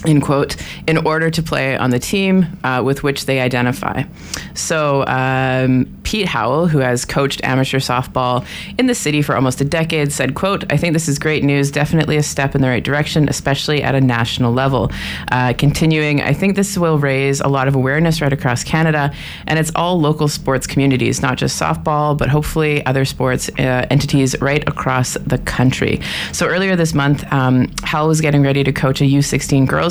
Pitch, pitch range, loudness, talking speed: 140 Hz, 130-155 Hz, -16 LUFS, 195 wpm